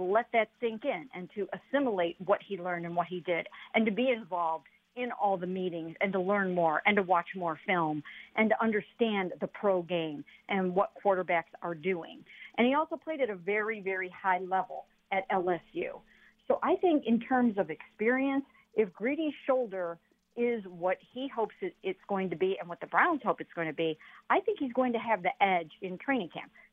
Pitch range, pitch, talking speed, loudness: 180-235 Hz, 195 Hz, 205 wpm, -31 LUFS